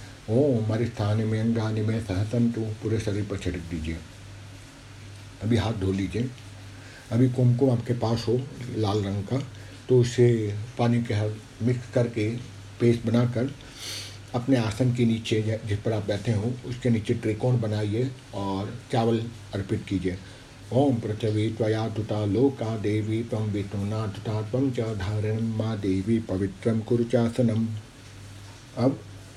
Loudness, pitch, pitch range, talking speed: -26 LUFS, 110 Hz, 105-120 Hz, 135 wpm